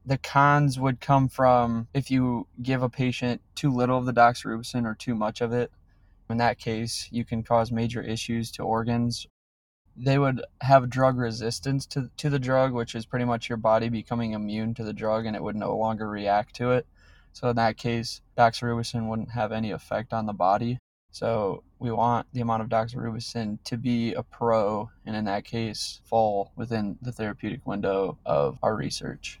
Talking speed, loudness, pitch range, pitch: 190 wpm, -26 LUFS, 110-125 Hz, 115 Hz